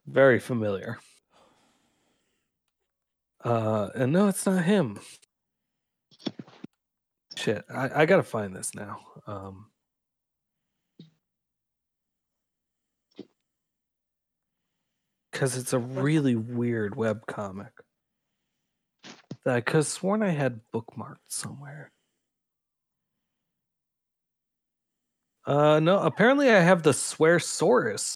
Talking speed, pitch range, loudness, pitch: 85 wpm, 110-170 Hz, -25 LUFS, 130 Hz